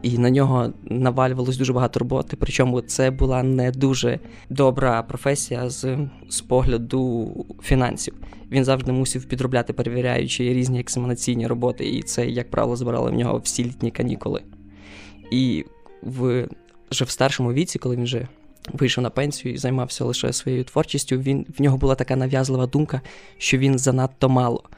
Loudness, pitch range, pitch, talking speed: -22 LUFS, 120-135 Hz, 130 Hz, 155 wpm